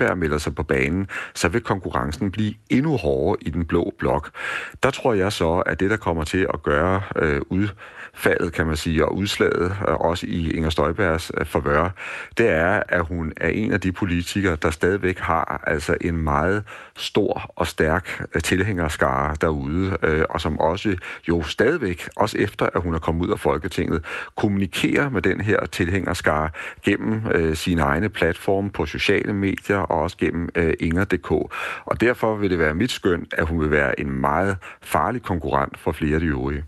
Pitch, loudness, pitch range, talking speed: 85 Hz, -22 LUFS, 80-95 Hz, 180 wpm